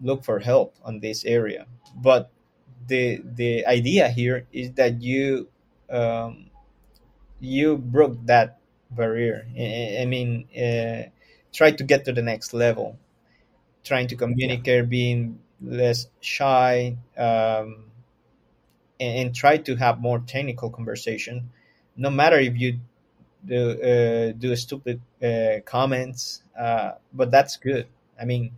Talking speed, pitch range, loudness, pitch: 130 wpm, 115-130 Hz, -23 LUFS, 120 Hz